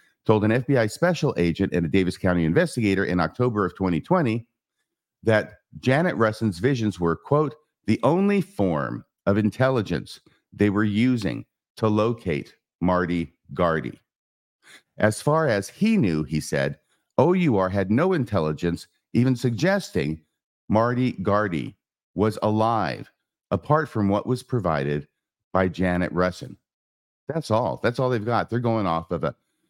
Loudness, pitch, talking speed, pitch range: -23 LUFS, 105 Hz, 135 wpm, 90-125 Hz